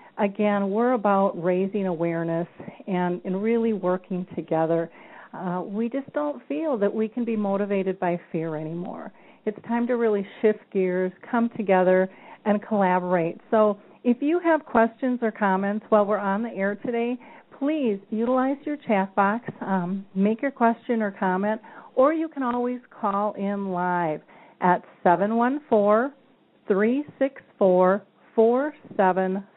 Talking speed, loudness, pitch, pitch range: 135 wpm, -24 LUFS, 210 Hz, 190-240 Hz